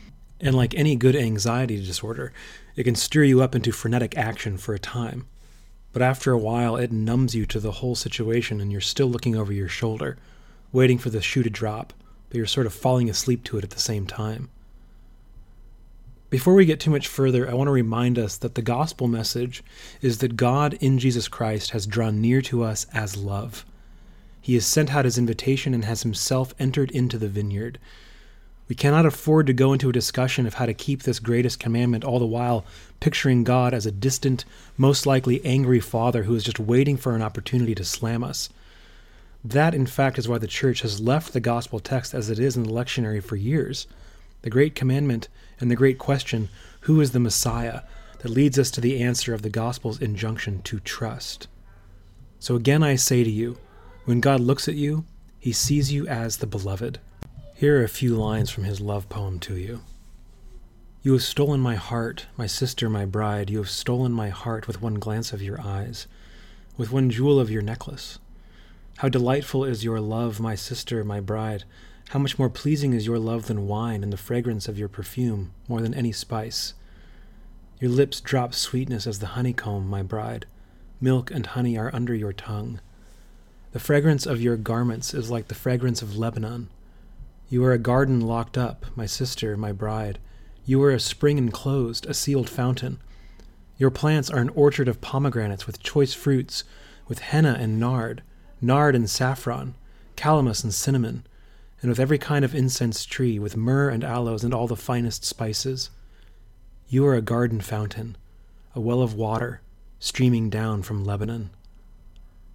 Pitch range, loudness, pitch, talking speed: 110-130 Hz, -24 LUFS, 120 Hz, 185 wpm